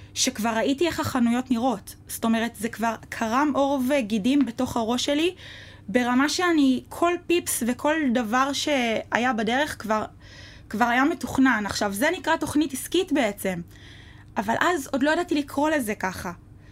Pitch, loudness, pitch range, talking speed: 260 Hz, -24 LUFS, 230-300 Hz, 145 wpm